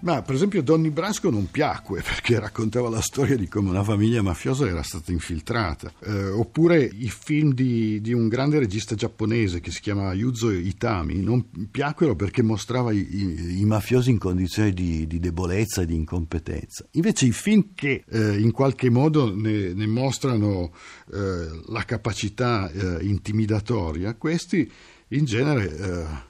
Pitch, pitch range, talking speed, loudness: 110 Hz, 95-125 Hz, 160 wpm, -24 LUFS